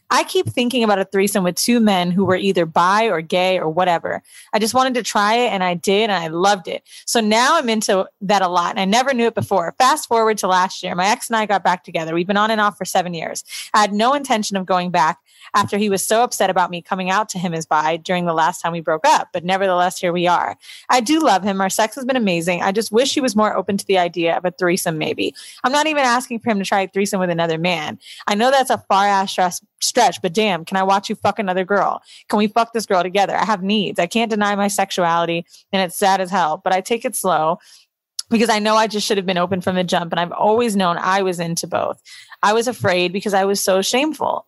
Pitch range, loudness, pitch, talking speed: 180-220 Hz, -18 LUFS, 195 Hz, 270 wpm